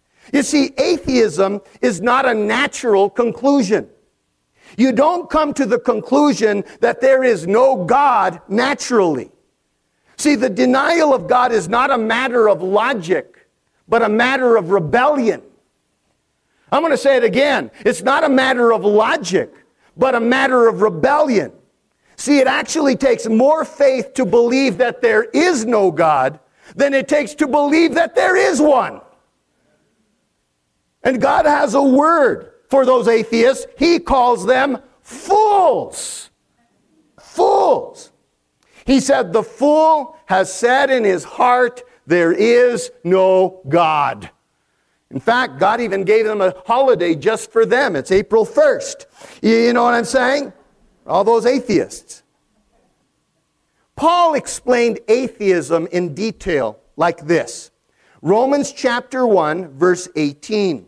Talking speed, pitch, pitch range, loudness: 135 wpm, 245 Hz, 215-280 Hz, -15 LUFS